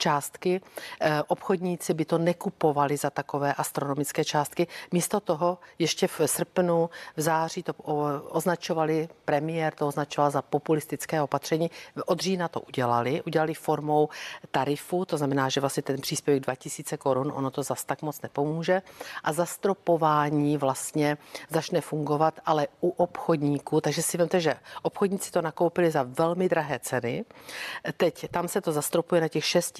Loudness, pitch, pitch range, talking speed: -27 LUFS, 155 Hz, 145-175 Hz, 145 wpm